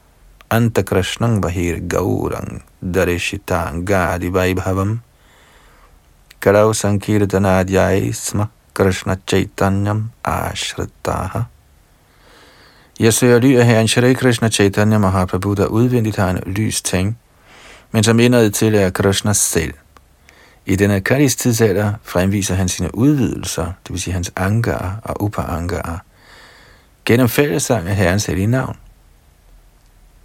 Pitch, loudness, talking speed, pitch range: 100 Hz, -16 LUFS, 110 wpm, 90-110 Hz